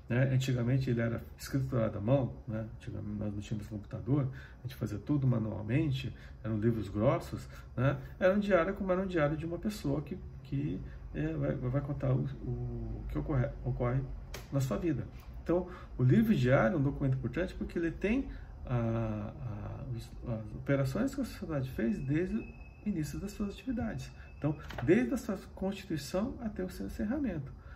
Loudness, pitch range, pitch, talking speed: -34 LUFS, 115-170 Hz, 135 Hz, 175 wpm